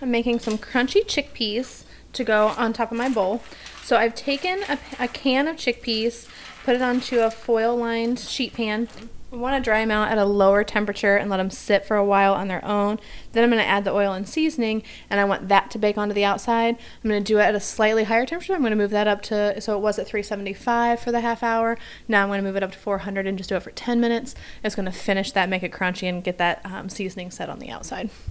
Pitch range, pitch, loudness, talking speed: 200-235 Hz, 215 Hz, -23 LUFS, 250 wpm